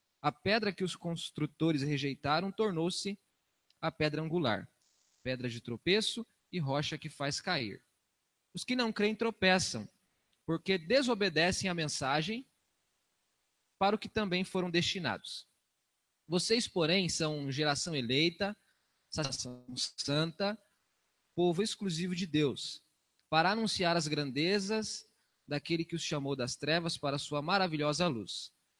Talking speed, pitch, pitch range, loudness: 120 wpm, 165 Hz, 145-195 Hz, -33 LUFS